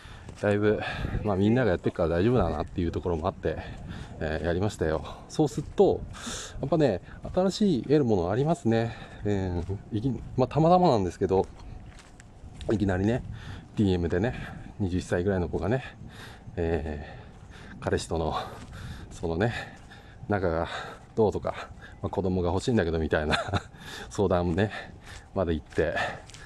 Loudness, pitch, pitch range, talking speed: -28 LUFS, 100 Hz, 90-115 Hz, 300 characters per minute